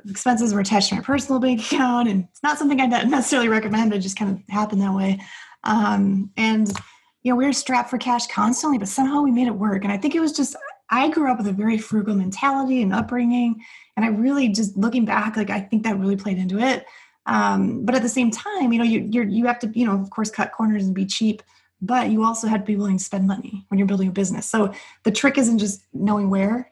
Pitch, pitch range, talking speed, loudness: 220 Hz, 205-250 Hz, 250 wpm, -21 LUFS